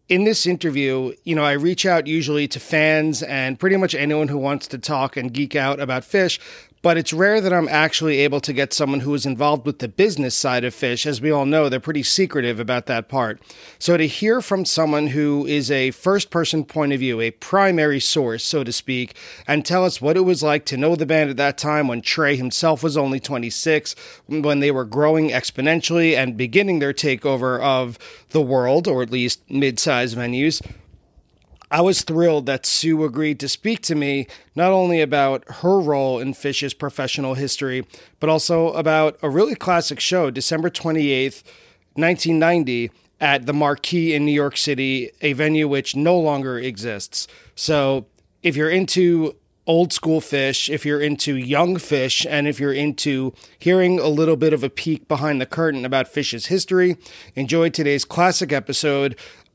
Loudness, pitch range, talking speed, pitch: -19 LUFS, 135-165 Hz, 190 wpm, 150 Hz